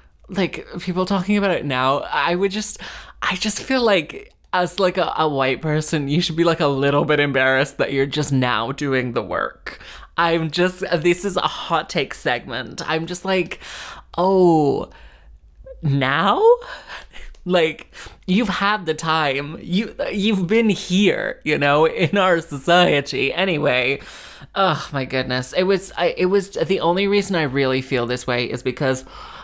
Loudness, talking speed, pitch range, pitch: -20 LUFS, 165 wpm, 140-190 Hz, 170 Hz